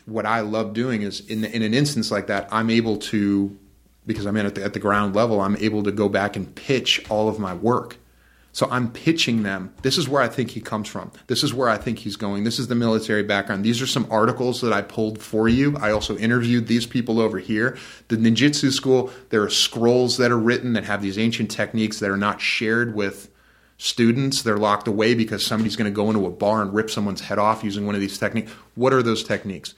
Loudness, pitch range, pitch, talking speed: -21 LUFS, 105-120 Hz, 110 Hz, 240 wpm